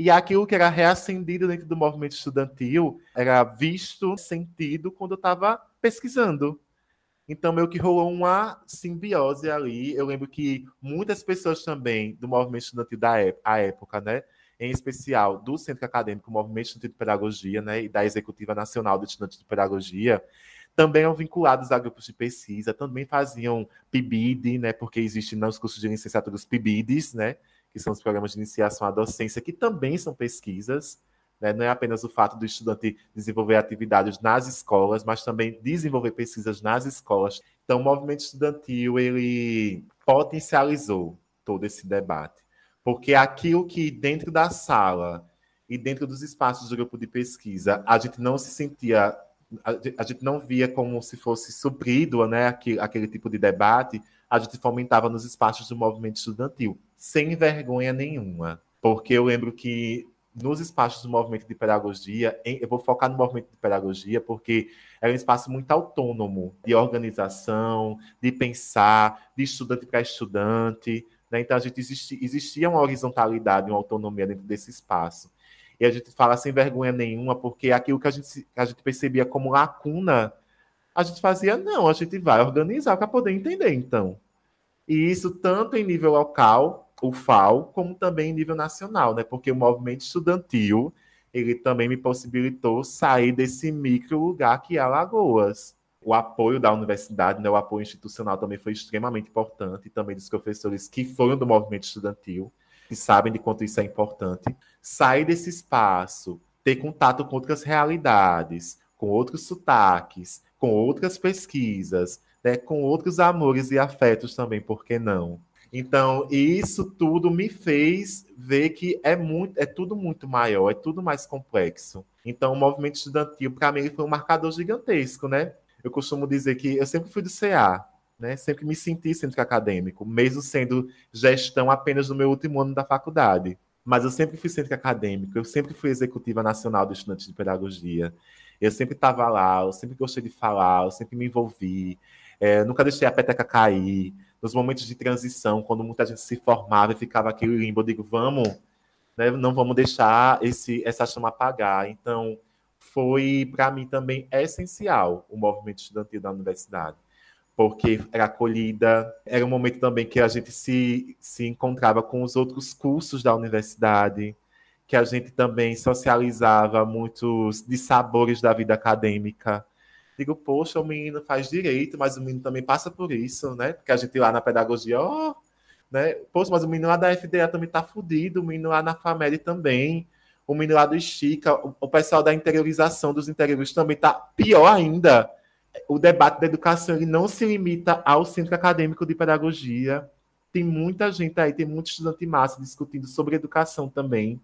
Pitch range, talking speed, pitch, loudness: 110-150 Hz, 165 wpm, 125 Hz, -23 LUFS